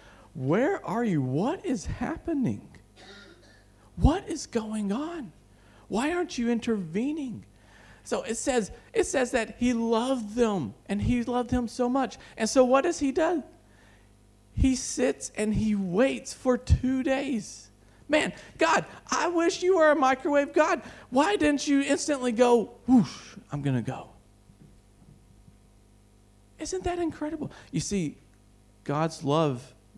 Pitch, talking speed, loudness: 245 Hz, 140 wpm, -27 LUFS